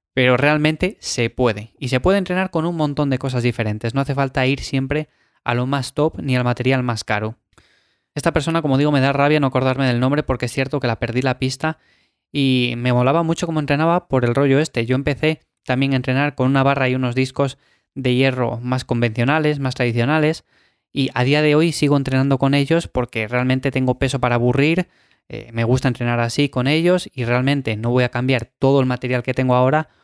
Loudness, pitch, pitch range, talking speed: -19 LUFS, 130 Hz, 125-145 Hz, 215 wpm